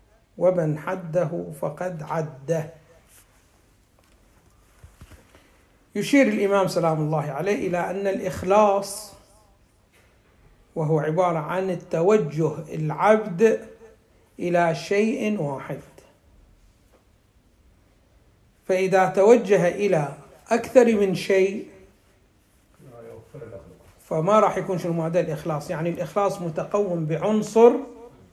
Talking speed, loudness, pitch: 75 wpm, -22 LUFS, 165 Hz